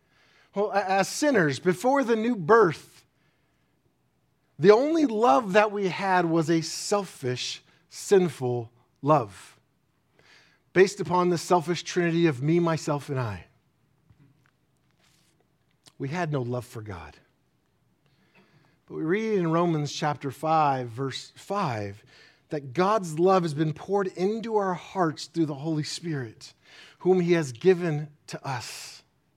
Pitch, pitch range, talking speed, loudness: 165 Hz, 140-190 Hz, 125 wpm, -25 LUFS